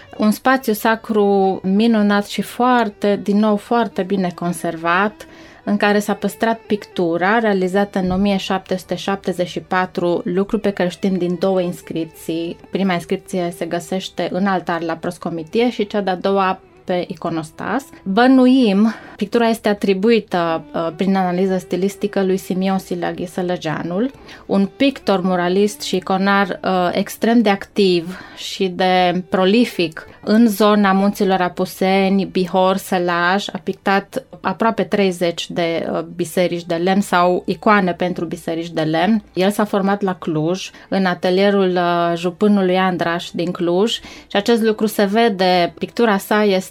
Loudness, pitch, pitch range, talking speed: -18 LUFS, 190 Hz, 180-210 Hz, 135 wpm